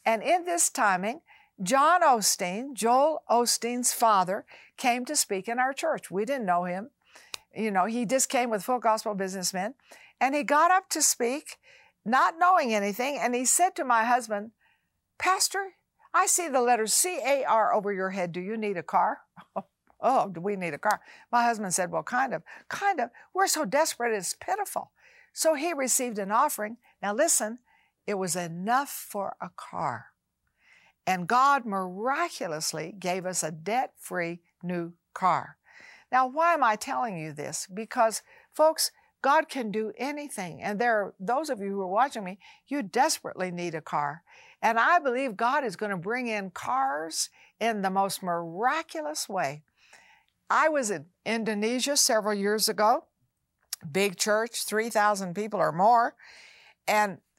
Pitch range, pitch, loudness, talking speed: 195-280 Hz, 230 Hz, -27 LUFS, 165 wpm